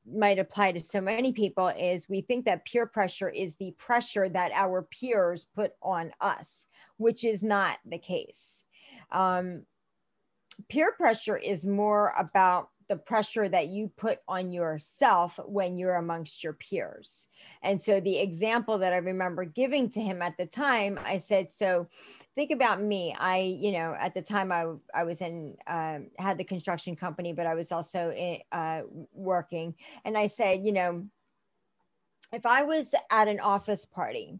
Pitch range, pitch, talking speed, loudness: 175-210 Hz, 190 Hz, 170 wpm, -29 LUFS